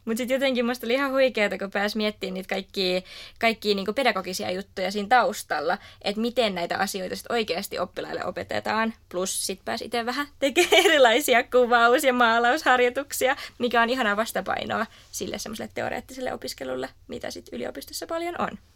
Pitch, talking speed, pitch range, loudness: 230 Hz, 155 wpm, 195-250 Hz, -24 LUFS